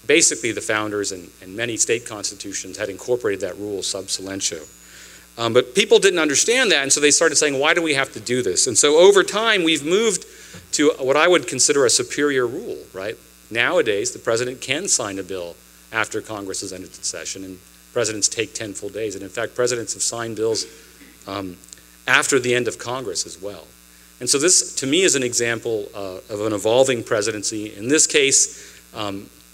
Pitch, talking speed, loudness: 115 Hz, 200 wpm, -19 LUFS